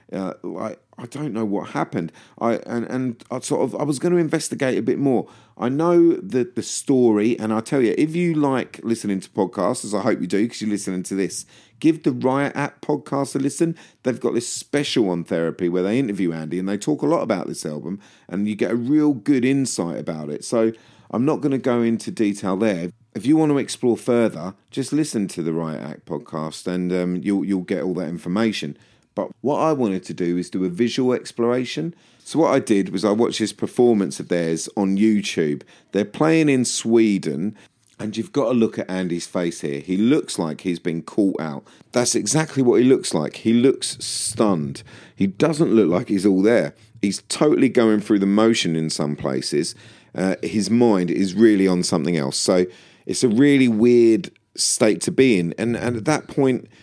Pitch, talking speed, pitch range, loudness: 110 Hz, 210 wpm, 95-130 Hz, -21 LUFS